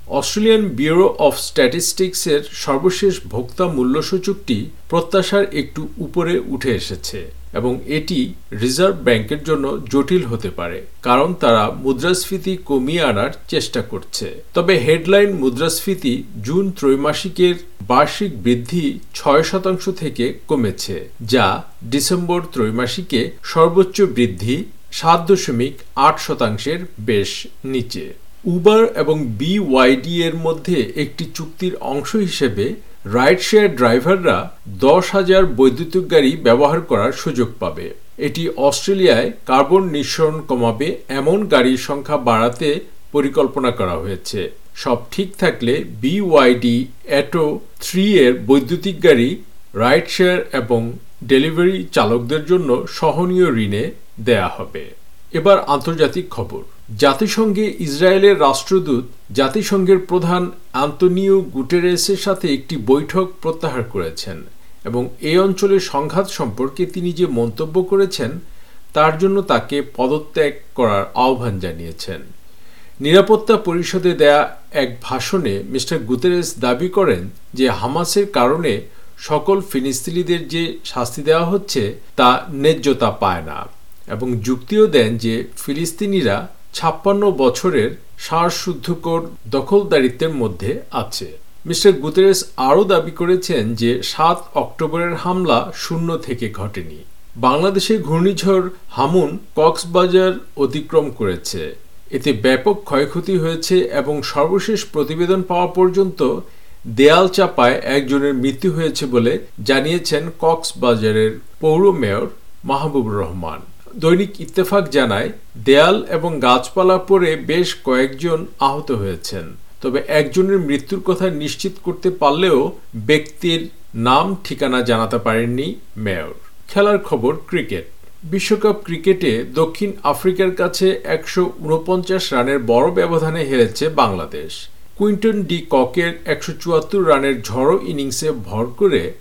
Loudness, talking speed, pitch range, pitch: -17 LUFS, 110 wpm, 130-185 Hz, 160 Hz